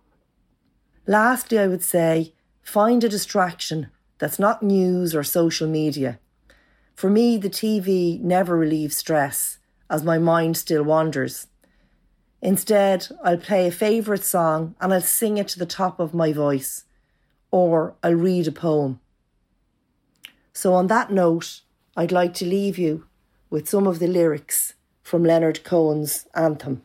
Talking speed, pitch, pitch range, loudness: 145 wpm, 175 Hz, 160-195 Hz, -21 LUFS